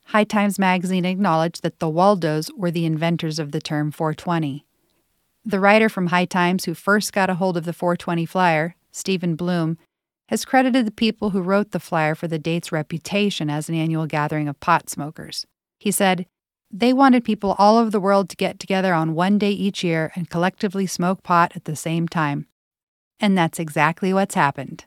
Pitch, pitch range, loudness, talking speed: 175 Hz, 160-200 Hz, -21 LUFS, 190 wpm